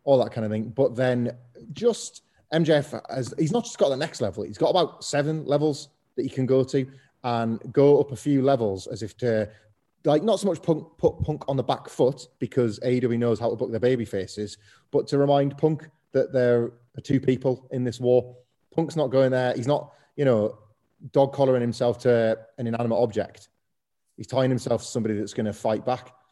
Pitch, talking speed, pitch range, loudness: 125 Hz, 210 wpm, 115-140 Hz, -25 LUFS